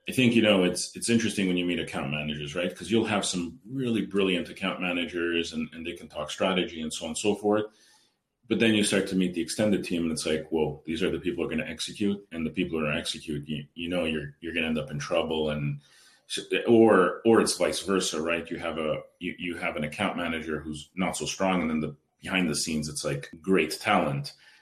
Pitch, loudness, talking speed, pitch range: 85 Hz, -27 LUFS, 250 wpm, 80-100 Hz